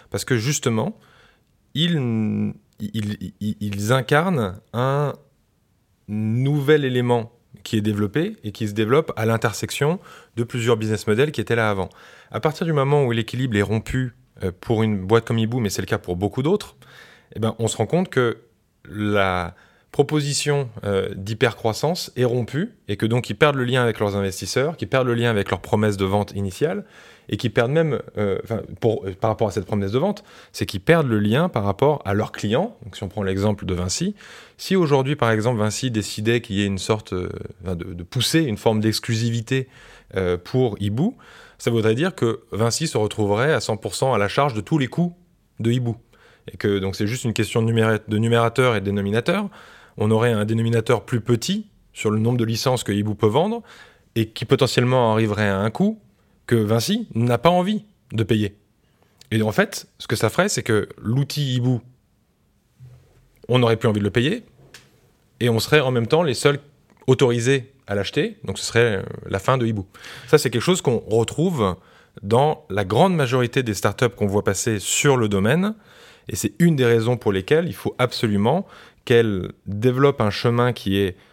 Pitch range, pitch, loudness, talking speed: 105-135 Hz, 115 Hz, -21 LUFS, 190 wpm